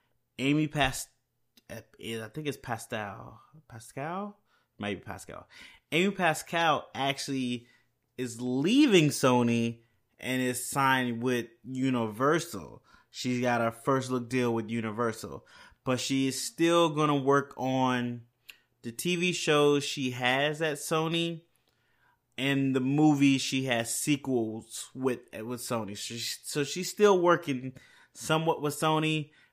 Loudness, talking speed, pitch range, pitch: -29 LUFS, 120 wpm, 120-150 Hz, 130 Hz